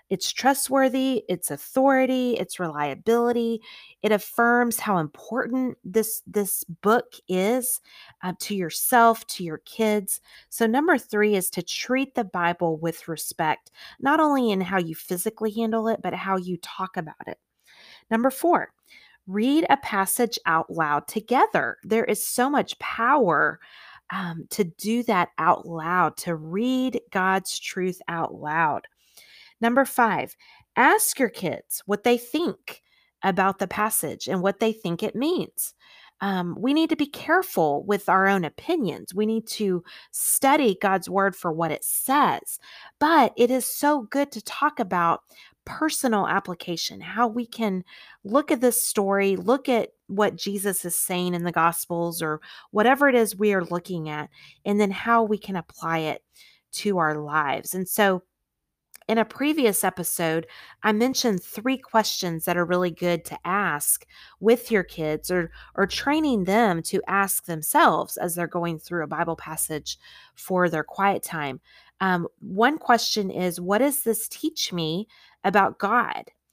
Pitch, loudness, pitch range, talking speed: 205 Hz, -24 LUFS, 175-240 Hz, 155 wpm